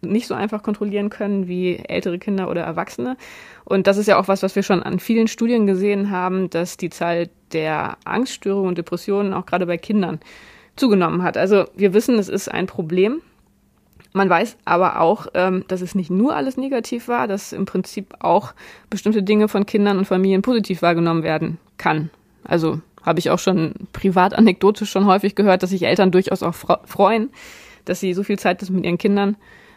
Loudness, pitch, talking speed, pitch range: -19 LUFS, 195 Hz, 185 wpm, 180-205 Hz